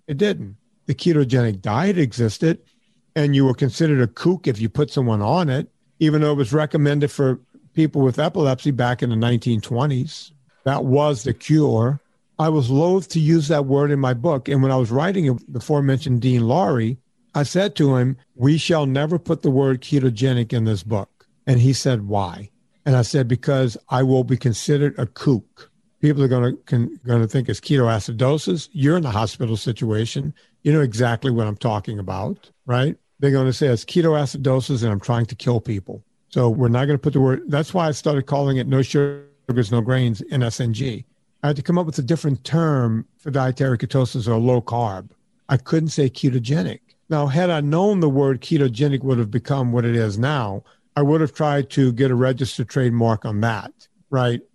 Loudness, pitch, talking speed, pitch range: -20 LUFS, 135 Hz, 200 wpm, 120-150 Hz